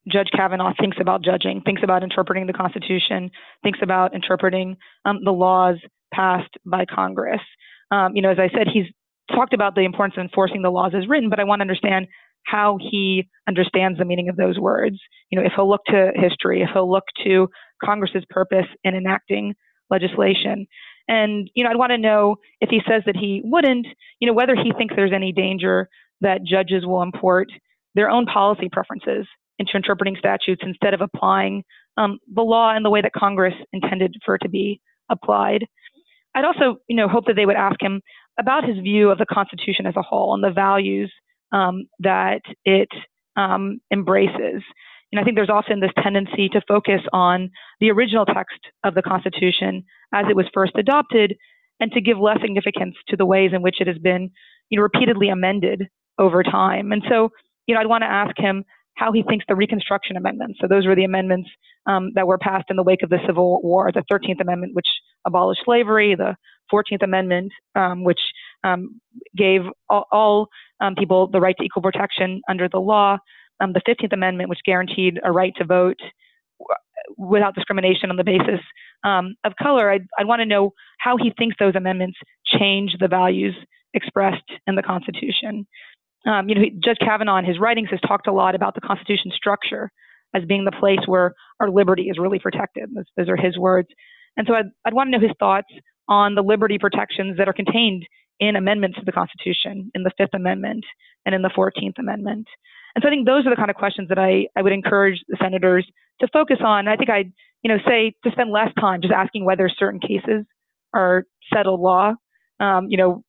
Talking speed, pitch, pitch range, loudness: 200 wpm, 195 Hz, 185-215 Hz, -19 LUFS